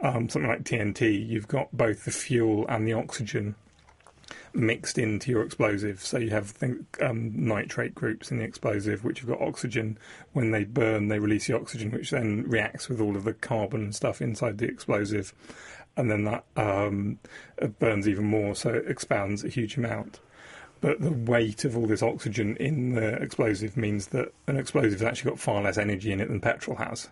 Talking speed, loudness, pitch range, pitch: 195 wpm, -28 LUFS, 105-120 Hz, 110 Hz